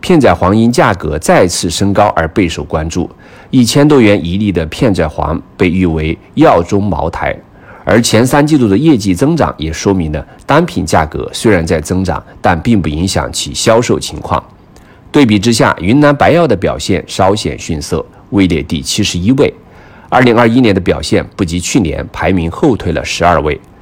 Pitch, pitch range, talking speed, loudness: 95 Hz, 85-115 Hz, 270 characters per minute, -11 LUFS